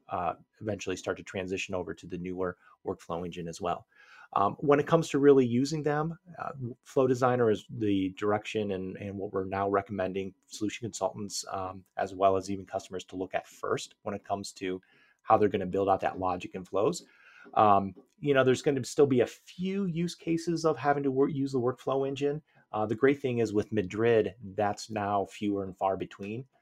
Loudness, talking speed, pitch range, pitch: -30 LUFS, 205 wpm, 95-135 Hz, 105 Hz